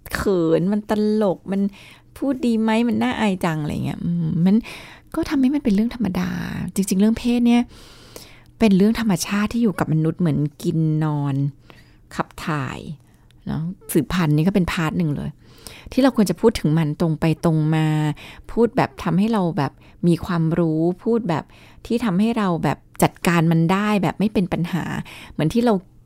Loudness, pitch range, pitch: -21 LUFS, 160-220 Hz, 185 Hz